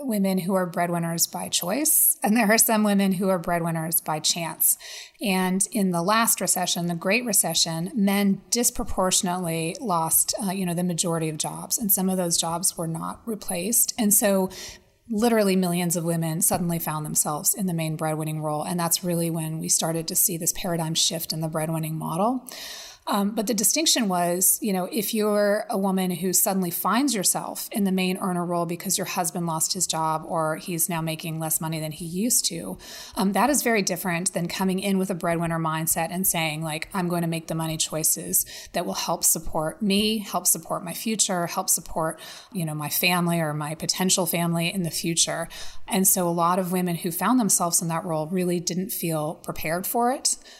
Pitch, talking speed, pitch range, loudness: 180 Hz, 200 wpm, 165-200 Hz, -23 LUFS